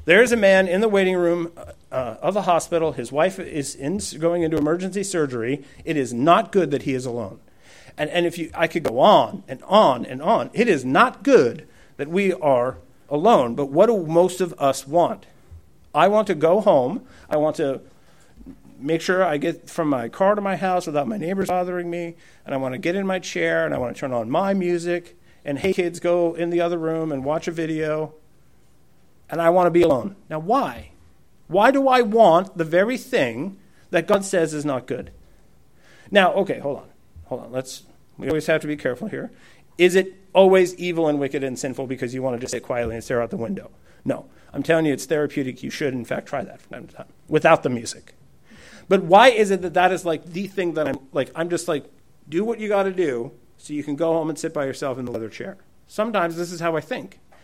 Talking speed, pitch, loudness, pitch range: 230 wpm, 165 Hz, -21 LUFS, 145-185 Hz